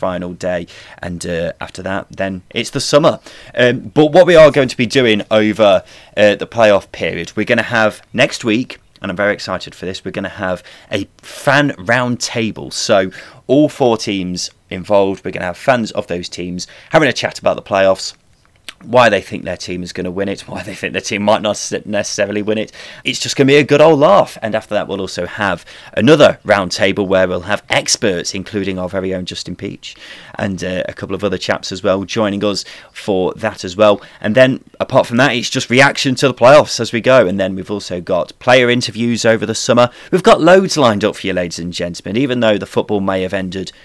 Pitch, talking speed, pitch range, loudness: 105 Hz, 225 wpm, 95-120 Hz, -14 LUFS